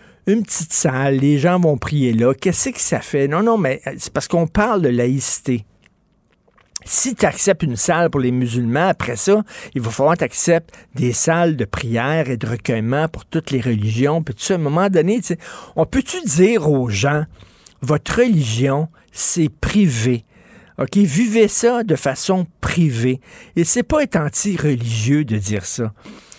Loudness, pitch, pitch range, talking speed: -18 LUFS, 155 Hz, 130-190 Hz, 175 wpm